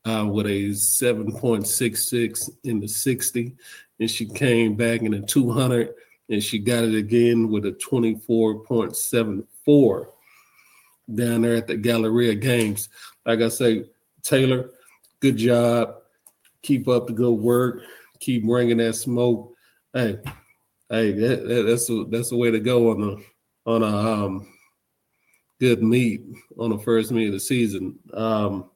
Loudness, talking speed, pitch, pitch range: -22 LUFS, 140 wpm, 115 Hz, 110-120 Hz